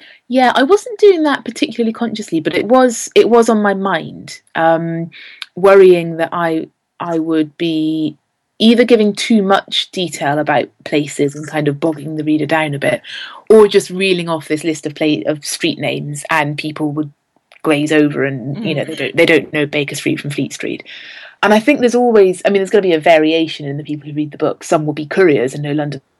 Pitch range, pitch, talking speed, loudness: 150-200 Hz, 160 Hz, 215 wpm, -14 LUFS